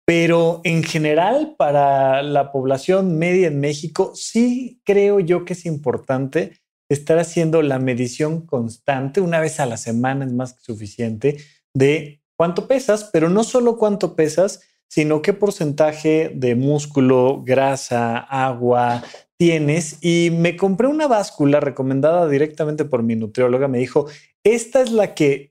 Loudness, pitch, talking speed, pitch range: -18 LUFS, 155 Hz, 145 wpm, 135-180 Hz